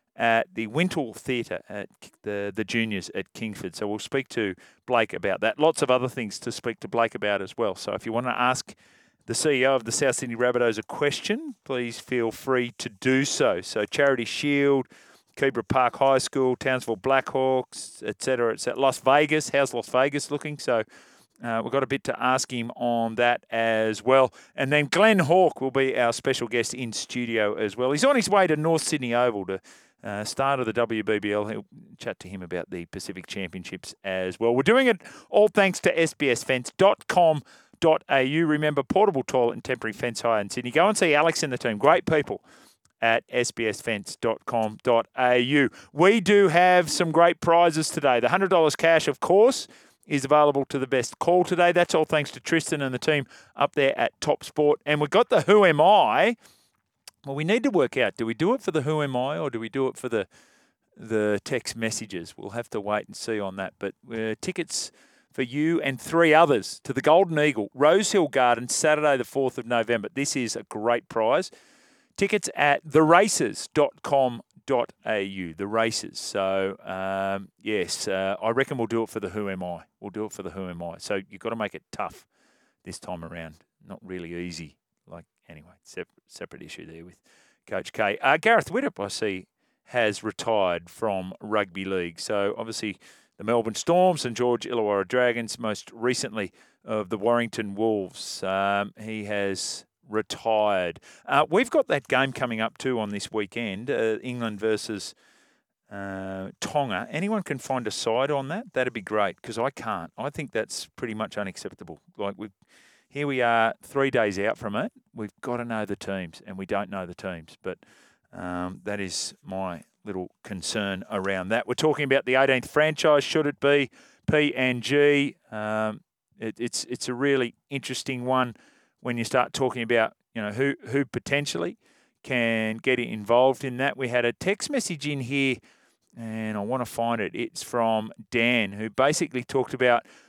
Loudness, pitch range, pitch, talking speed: -25 LUFS, 110-140 Hz, 125 Hz, 190 wpm